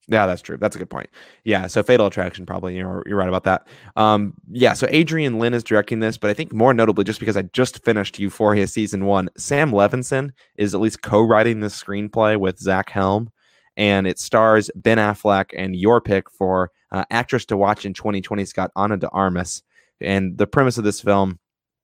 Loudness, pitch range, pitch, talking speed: -19 LUFS, 95-110 Hz, 105 Hz, 205 wpm